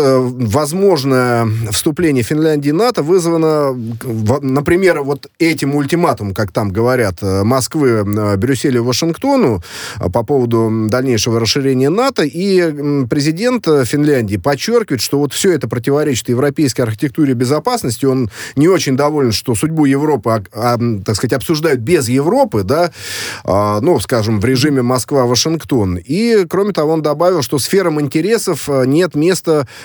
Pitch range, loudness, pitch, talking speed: 120-160 Hz, -14 LUFS, 140 Hz, 125 wpm